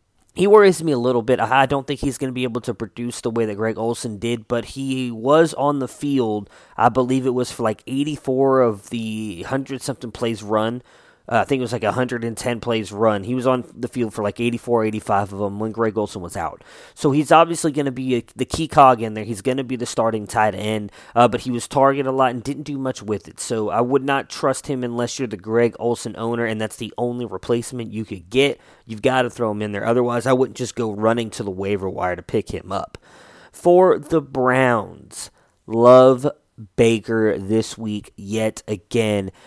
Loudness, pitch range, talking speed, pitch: -20 LUFS, 110-130 Hz, 225 wpm, 120 Hz